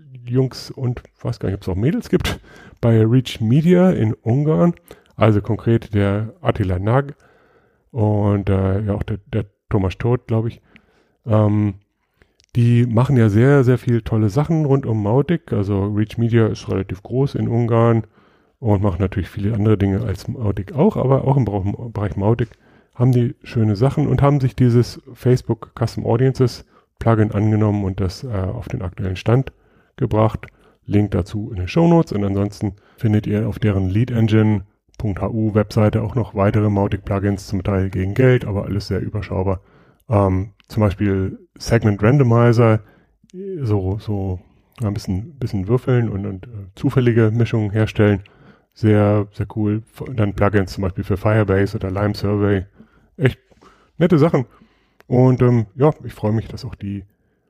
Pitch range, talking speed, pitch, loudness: 100-125 Hz, 160 wpm, 110 Hz, -19 LUFS